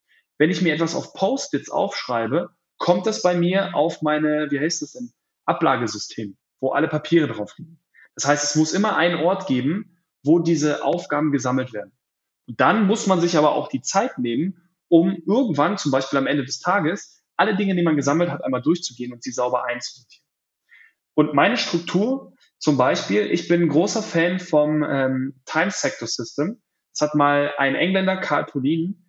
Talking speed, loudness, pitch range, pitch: 175 wpm, -21 LUFS, 140-180 Hz, 160 Hz